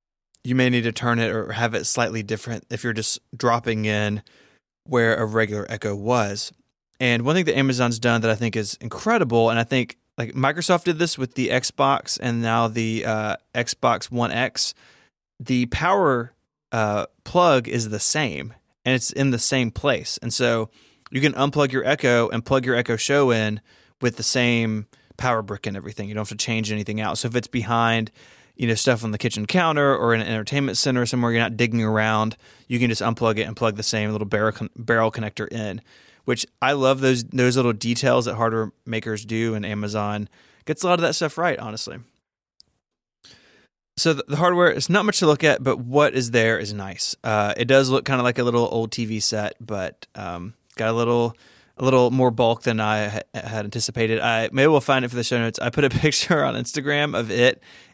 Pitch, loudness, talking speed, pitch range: 115 Hz, -21 LUFS, 210 wpm, 110-130 Hz